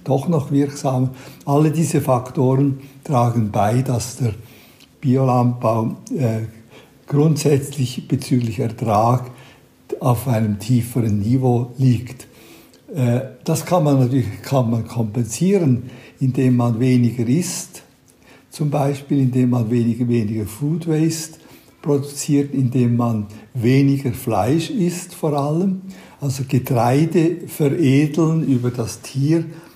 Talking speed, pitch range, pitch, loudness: 110 wpm, 120-145 Hz, 130 Hz, -19 LUFS